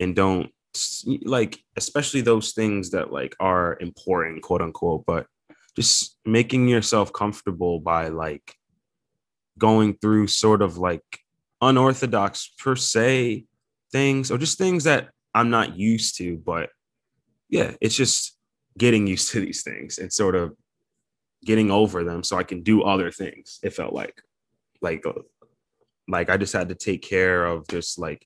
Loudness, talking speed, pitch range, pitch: -22 LUFS, 150 wpm, 90-120 Hz, 110 Hz